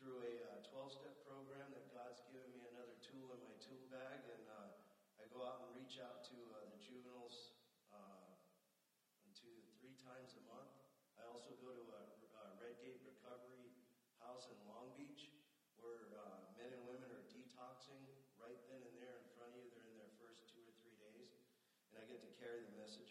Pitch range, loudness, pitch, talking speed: 115-125 Hz, -60 LUFS, 125 Hz, 195 wpm